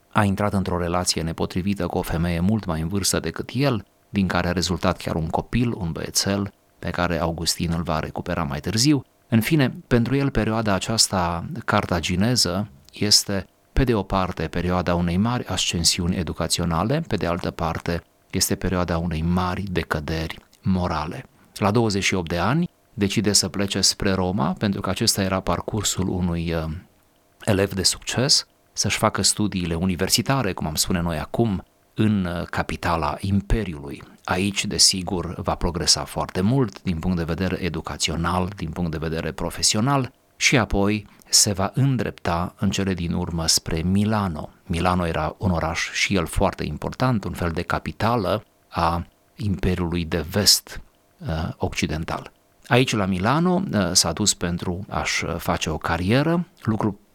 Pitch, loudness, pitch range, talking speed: 95 Hz, -22 LUFS, 85-105 Hz, 150 wpm